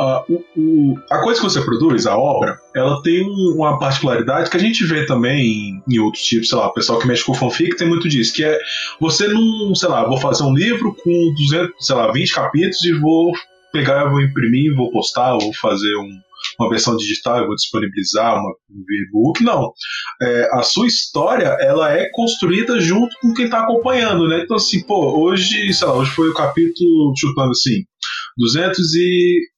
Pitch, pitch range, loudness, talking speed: 165 Hz, 135-185 Hz, -16 LUFS, 200 wpm